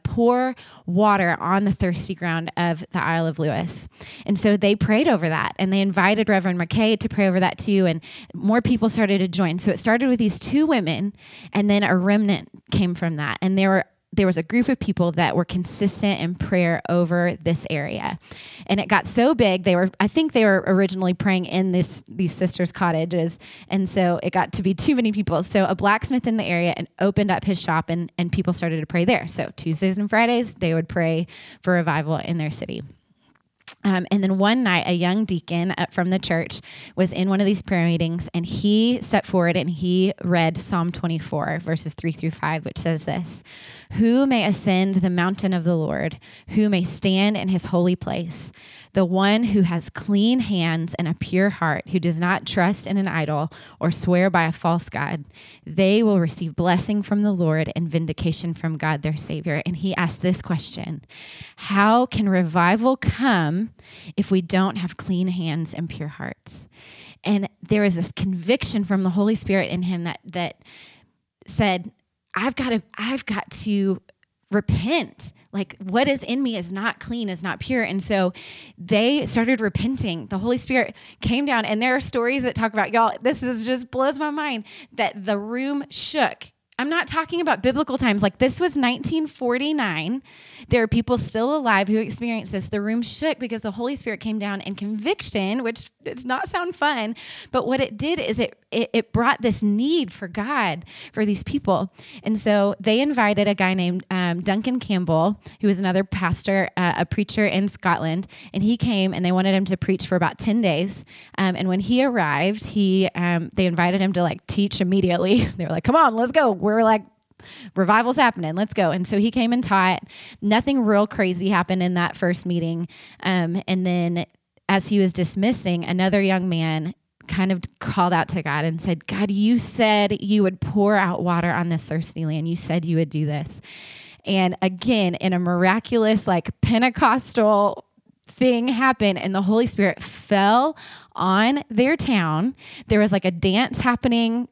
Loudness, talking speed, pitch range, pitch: -21 LUFS, 195 wpm, 175-220 Hz, 195 Hz